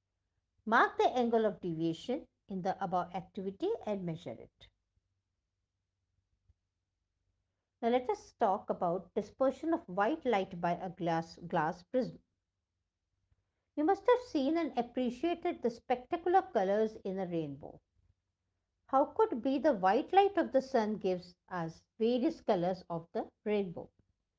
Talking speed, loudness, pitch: 135 wpm, -34 LUFS, 190 Hz